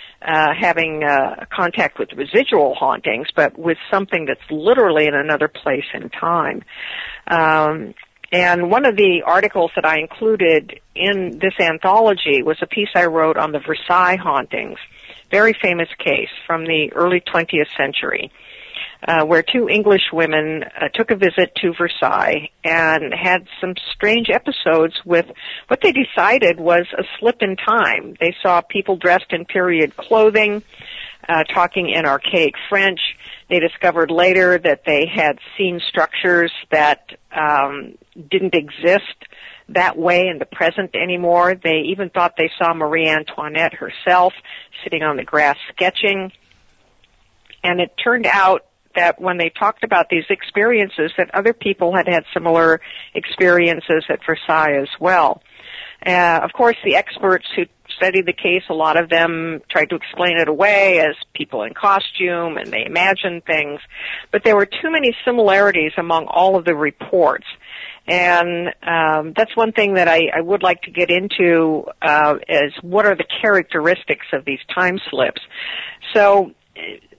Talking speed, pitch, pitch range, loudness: 155 wpm, 175 Hz, 165-195 Hz, -16 LUFS